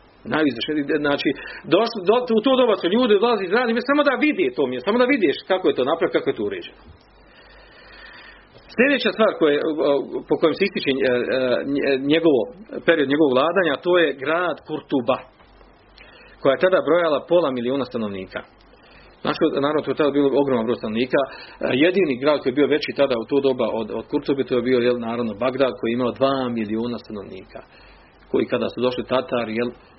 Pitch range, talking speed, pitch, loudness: 125-200 Hz, 180 wpm, 140 Hz, -20 LUFS